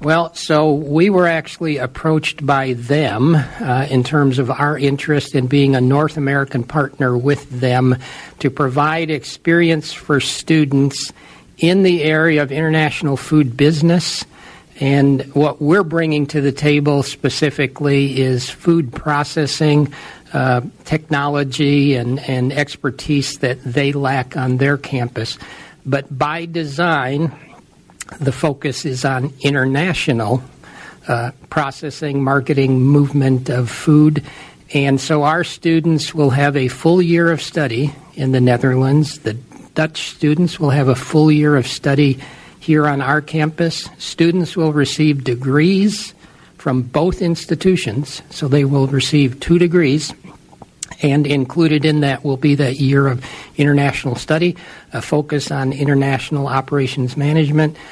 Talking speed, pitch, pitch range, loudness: 135 wpm, 145 Hz, 135-155 Hz, -16 LUFS